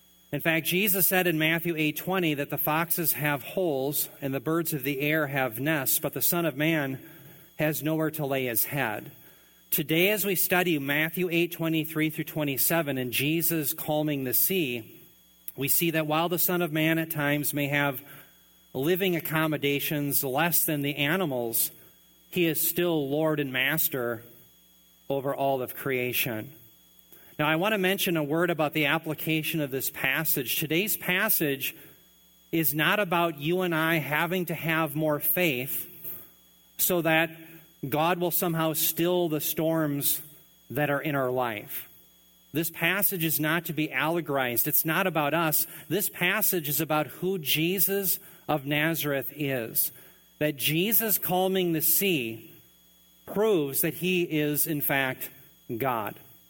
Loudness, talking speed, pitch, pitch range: -26 LUFS, 150 wpm, 155 Hz, 140-170 Hz